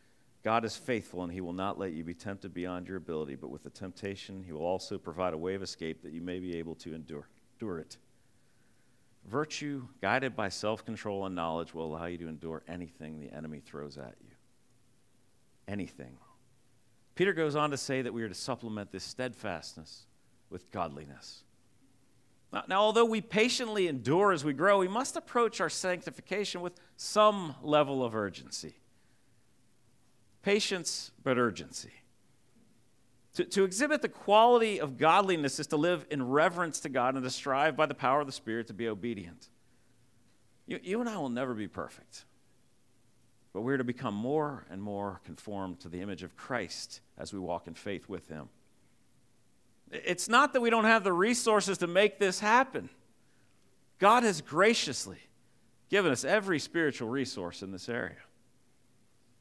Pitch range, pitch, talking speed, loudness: 95-155 Hz, 120 Hz, 170 wpm, -31 LUFS